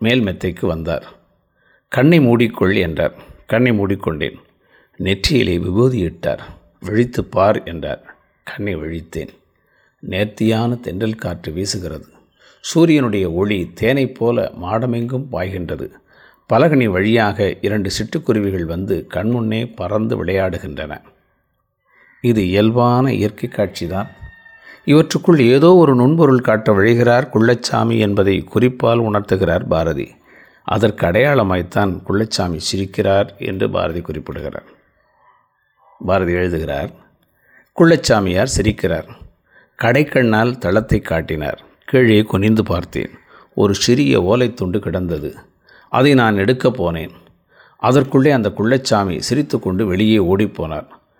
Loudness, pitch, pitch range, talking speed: -16 LUFS, 110 Hz, 95-120 Hz, 95 wpm